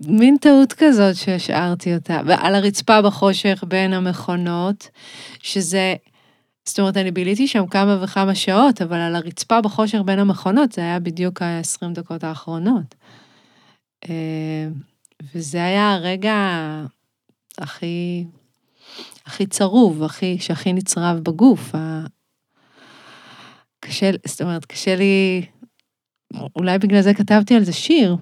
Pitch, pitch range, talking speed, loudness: 185 Hz, 170-200 Hz, 115 wpm, -18 LUFS